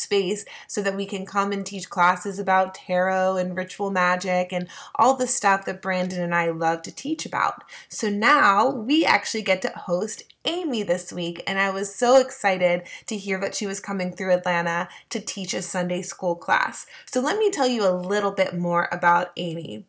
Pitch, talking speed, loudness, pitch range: 190 Hz, 200 wpm, -23 LUFS, 180-205 Hz